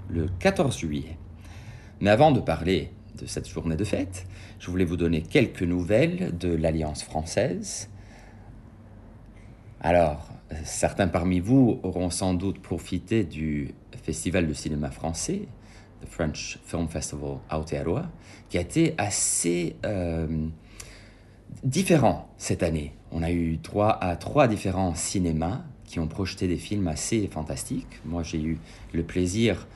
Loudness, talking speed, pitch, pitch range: -27 LUFS, 135 wpm, 90 Hz, 80-105 Hz